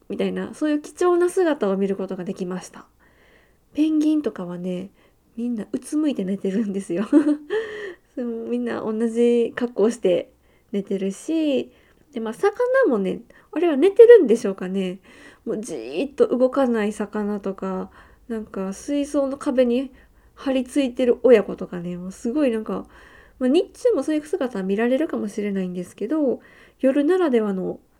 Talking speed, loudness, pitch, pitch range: 325 characters per minute, -22 LUFS, 240 Hz, 195-300 Hz